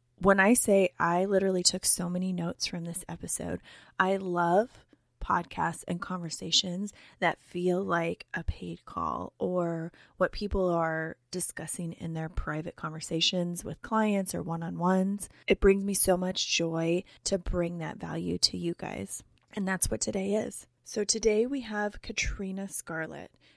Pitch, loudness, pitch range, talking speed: 180 Hz, -29 LUFS, 170-195 Hz, 160 wpm